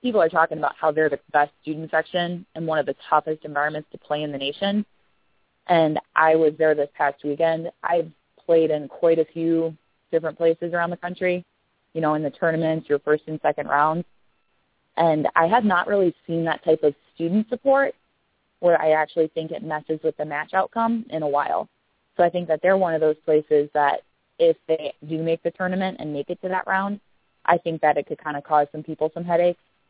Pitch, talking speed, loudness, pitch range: 160 Hz, 215 wpm, -23 LUFS, 150-175 Hz